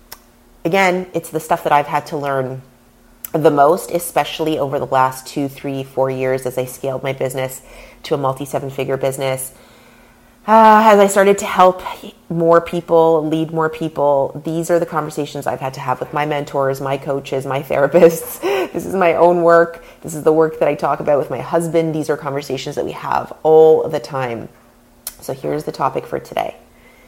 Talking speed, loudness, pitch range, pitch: 195 wpm, -16 LUFS, 135-165 Hz, 150 Hz